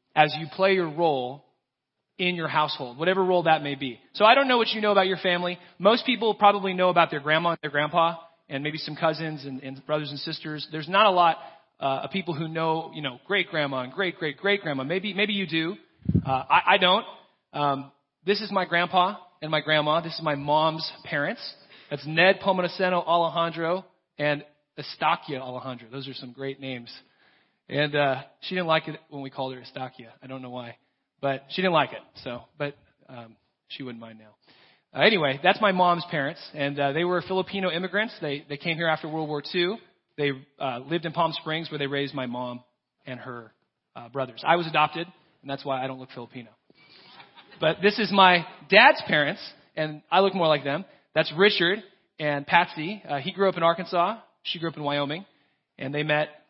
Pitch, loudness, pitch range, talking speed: 155 Hz, -24 LUFS, 140-180 Hz, 205 wpm